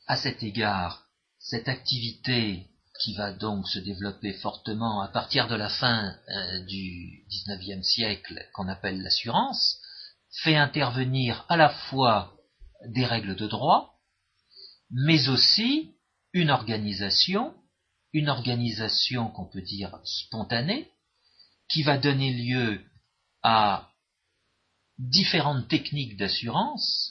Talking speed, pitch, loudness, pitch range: 110 wpm, 115 Hz, -26 LUFS, 100-140 Hz